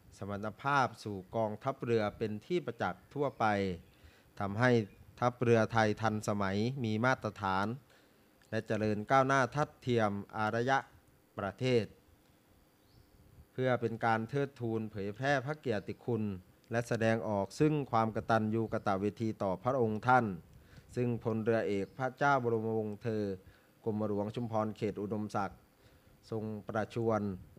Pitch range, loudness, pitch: 105-120 Hz, -34 LUFS, 110 Hz